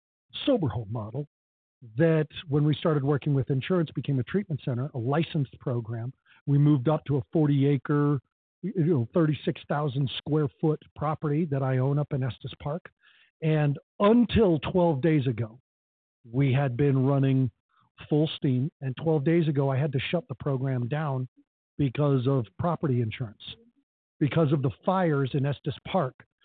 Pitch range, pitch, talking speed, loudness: 130-155 Hz, 145 Hz, 155 wpm, -27 LUFS